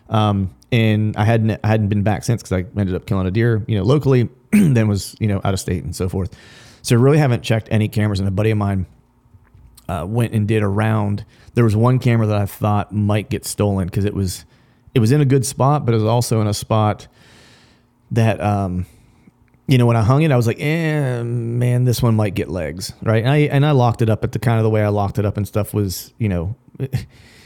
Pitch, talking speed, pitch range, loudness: 110 Hz, 250 wpm, 105-120 Hz, -18 LUFS